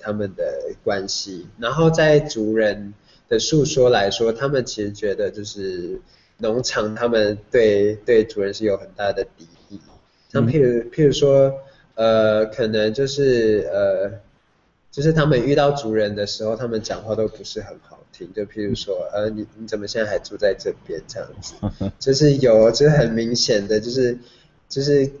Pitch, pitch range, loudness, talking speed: 120 Hz, 110-145 Hz, -19 LUFS, 250 characters per minute